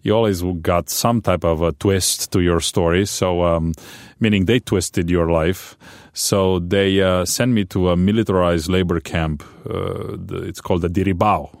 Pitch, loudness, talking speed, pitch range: 90 Hz, -19 LUFS, 170 wpm, 85-100 Hz